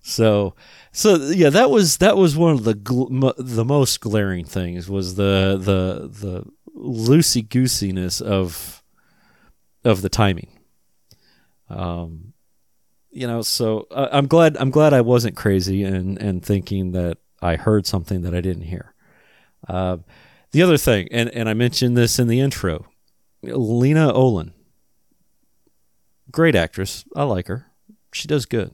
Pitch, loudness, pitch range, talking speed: 110 Hz, -19 LUFS, 95-130 Hz, 150 wpm